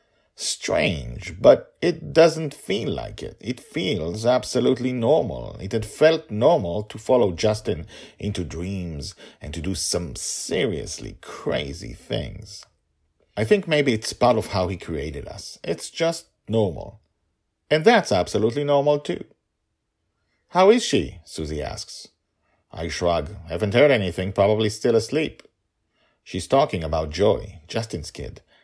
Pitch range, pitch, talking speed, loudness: 90-145 Hz, 110 Hz, 135 wpm, -22 LUFS